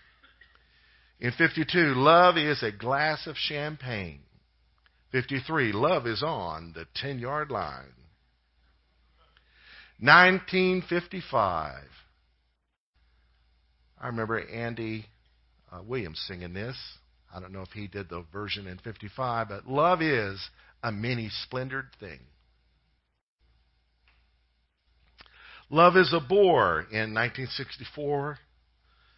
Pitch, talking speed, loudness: 100 Hz, 95 wpm, -26 LUFS